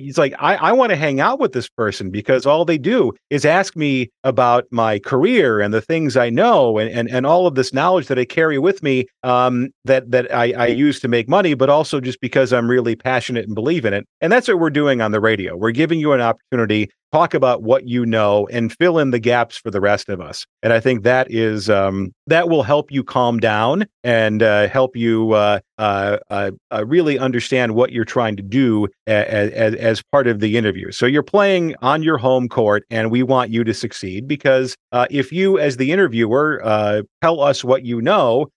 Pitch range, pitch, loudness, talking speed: 110-140 Hz, 125 Hz, -17 LUFS, 225 wpm